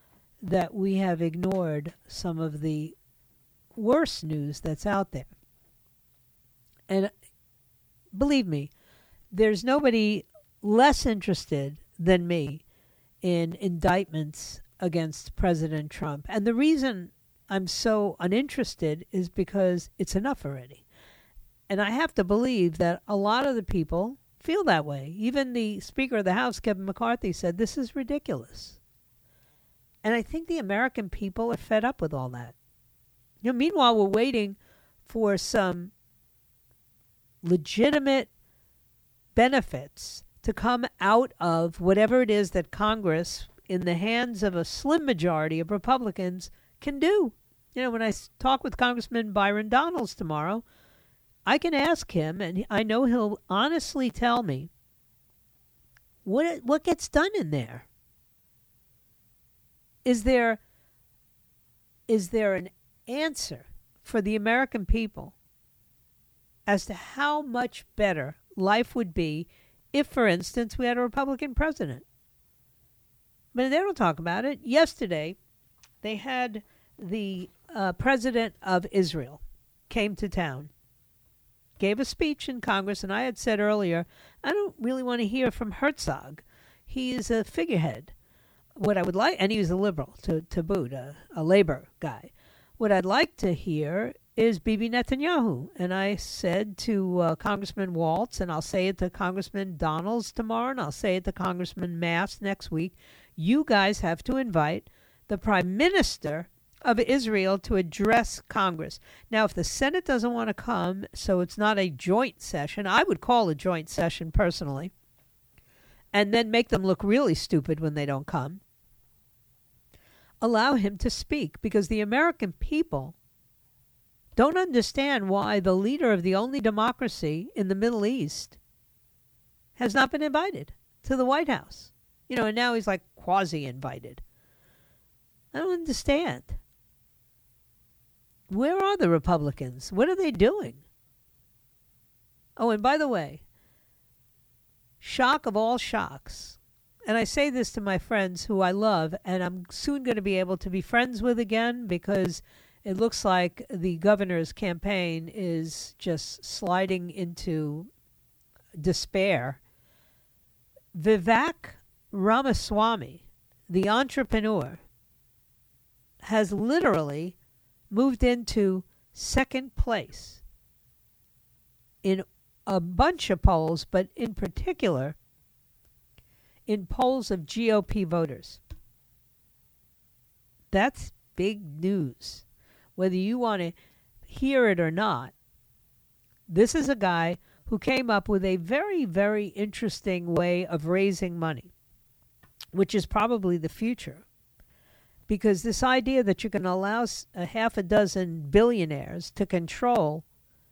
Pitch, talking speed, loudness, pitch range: 200 Hz, 135 wpm, -27 LUFS, 170-235 Hz